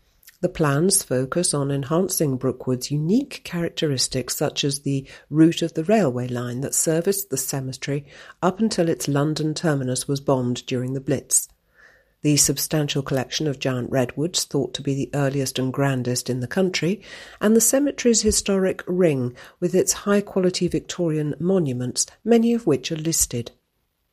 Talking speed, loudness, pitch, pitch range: 155 wpm, -22 LUFS, 150 Hz, 135-180 Hz